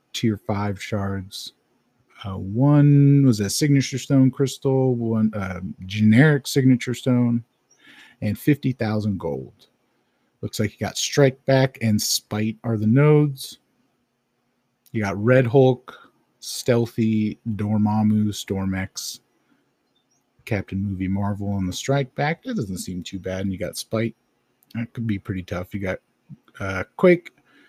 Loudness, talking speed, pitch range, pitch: -22 LUFS, 135 wpm, 100-130 Hz, 115 Hz